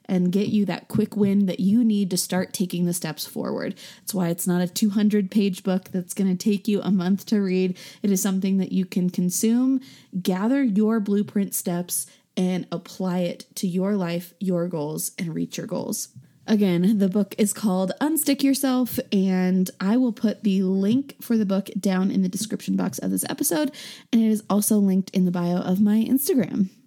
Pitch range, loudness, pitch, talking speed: 185-215 Hz, -23 LUFS, 195 Hz, 200 wpm